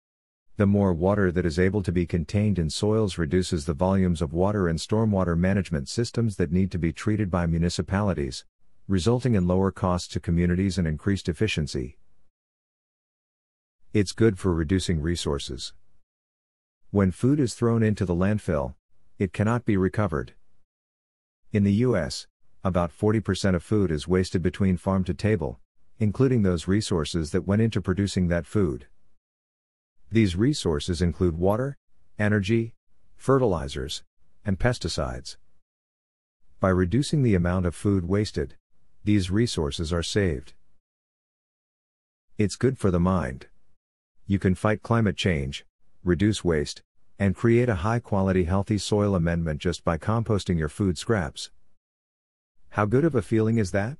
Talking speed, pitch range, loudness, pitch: 140 wpm, 85-105 Hz, -25 LUFS, 95 Hz